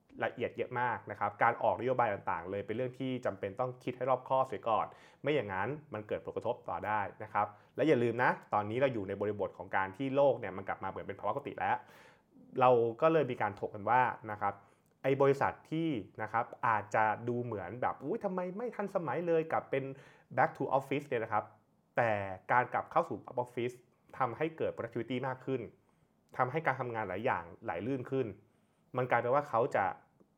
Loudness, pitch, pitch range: -34 LUFS, 125 Hz, 110-140 Hz